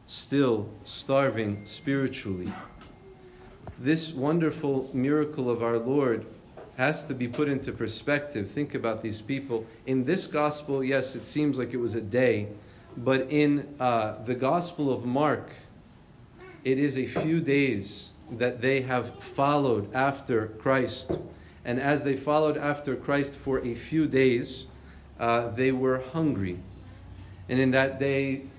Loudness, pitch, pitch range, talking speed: -28 LUFS, 130 Hz, 115-140 Hz, 140 wpm